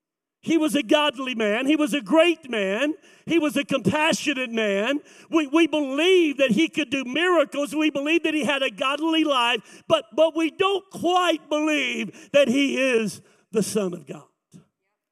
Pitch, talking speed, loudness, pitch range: 295 Hz, 175 wpm, -22 LUFS, 255-320 Hz